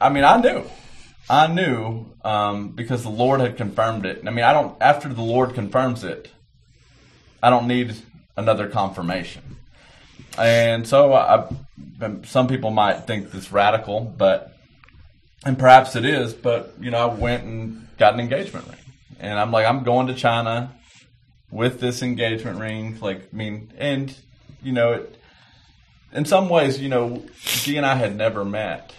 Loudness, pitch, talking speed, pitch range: -20 LUFS, 120 Hz, 170 wpm, 110-130 Hz